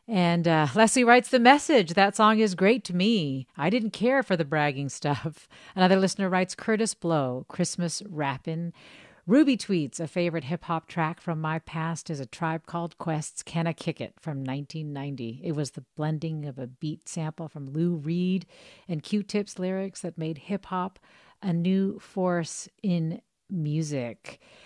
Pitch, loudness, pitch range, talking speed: 170 Hz, -27 LUFS, 155-195 Hz, 170 wpm